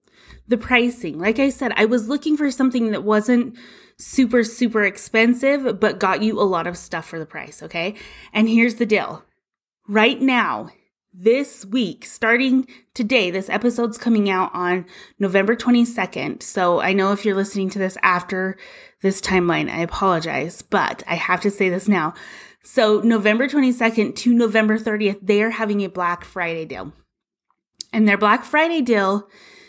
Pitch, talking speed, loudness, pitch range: 215 Hz, 160 wpm, -19 LUFS, 190-240 Hz